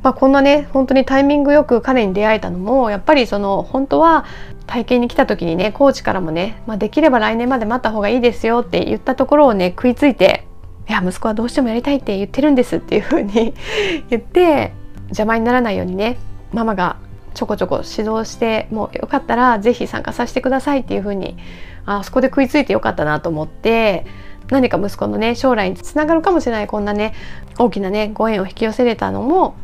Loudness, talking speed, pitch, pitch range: -16 LUFS, 445 characters per minute, 230 Hz, 205-265 Hz